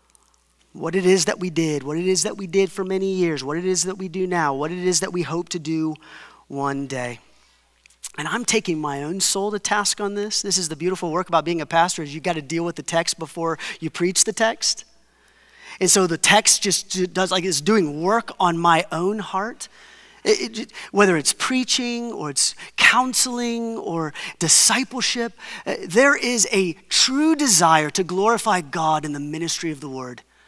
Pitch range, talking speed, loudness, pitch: 160-210 Hz, 205 wpm, -20 LUFS, 185 Hz